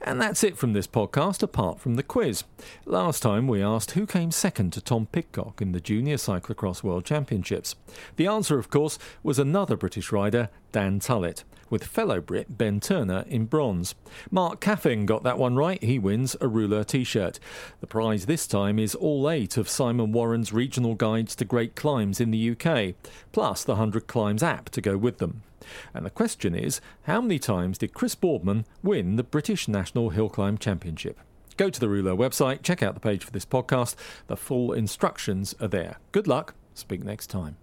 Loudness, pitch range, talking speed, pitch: -26 LUFS, 100-145 Hz, 190 wpm, 115 Hz